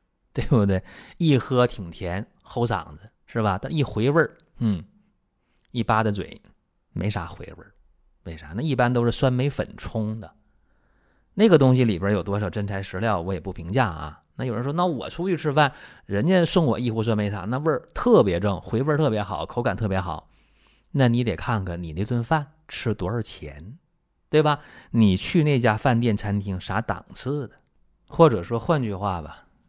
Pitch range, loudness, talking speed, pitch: 95-135 Hz, -24 LUFS, 260 characters per minute, 110 Hz